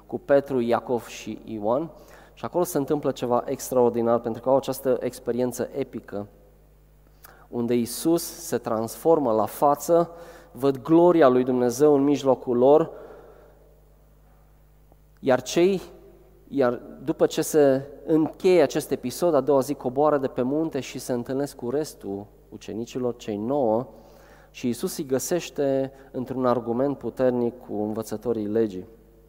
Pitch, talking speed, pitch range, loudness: 130 Hz, 130 wpm, 120-150 Hz, -24 LUFS